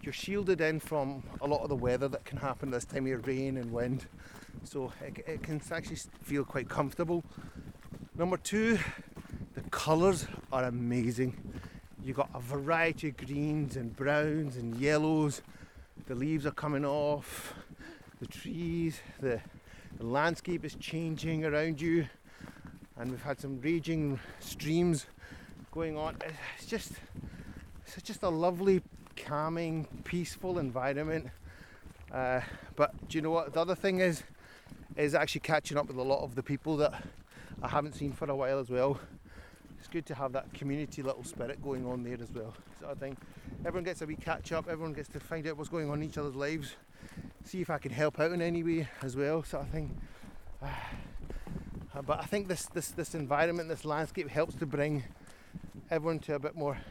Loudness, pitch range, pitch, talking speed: -34 LUFS, 135-165 Hz, 150 Hz, 180 wpm